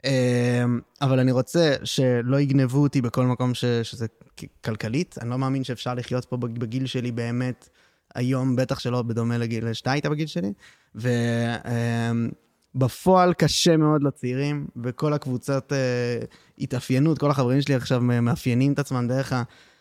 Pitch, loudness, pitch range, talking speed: 125 Hz, -24 LUFS, 120-135 Hz, 135 wpm